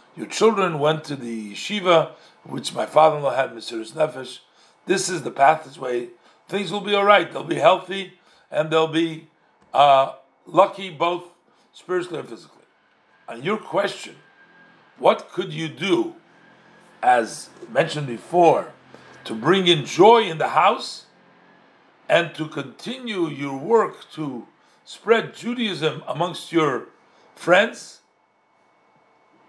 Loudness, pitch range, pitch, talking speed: -21 LUFS, 150-195 Hz, 165 Hz, 130 wpm